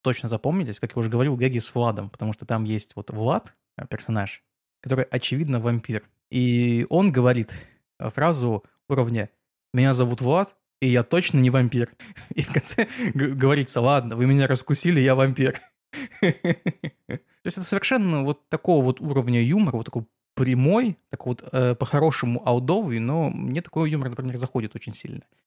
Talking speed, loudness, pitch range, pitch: 155 wpm, -23 LUFS, 120-155 Hz, 130 Hz